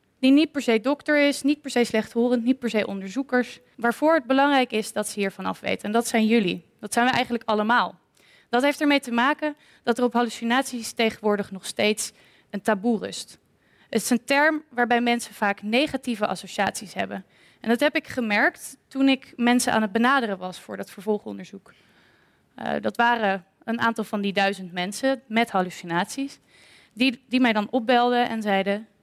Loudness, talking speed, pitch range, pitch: -23 LUFS, 185 wpm, 210-260 Hz, 235 Hz